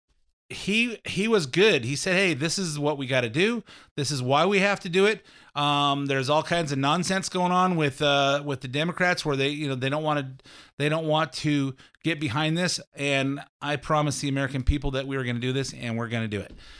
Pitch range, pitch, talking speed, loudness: 135-170 Hz, 145 Hz, 245 wpm, -25 LUFS